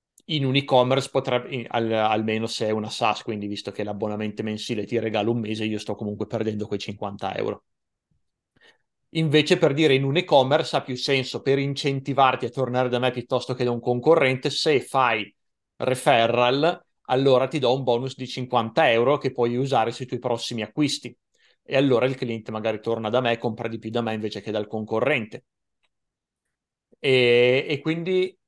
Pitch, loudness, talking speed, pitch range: 125 Hz, -23 LUFS, 180 wpm, 110-135 Hz